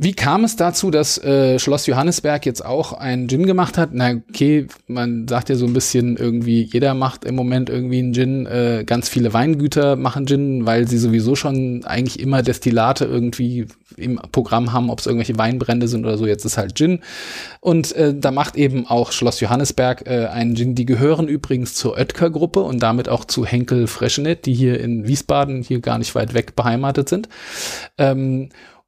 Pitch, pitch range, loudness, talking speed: 125 Hz, 120-140 Hz, -18 LUFS, 190 wpm